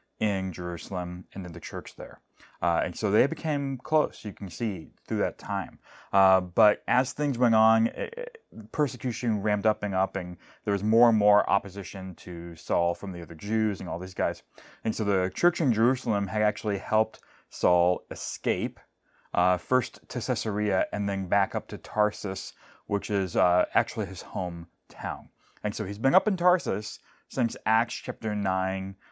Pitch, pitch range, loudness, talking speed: 105 Hz, 95-115 Hz, -27 LUFS, 180 wpm